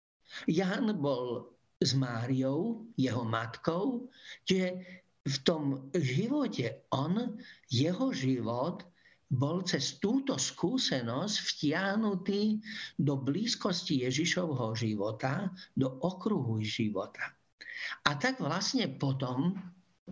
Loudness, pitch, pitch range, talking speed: -33 LUFS, 165 Hz, 130-200 Hz, 85 wpm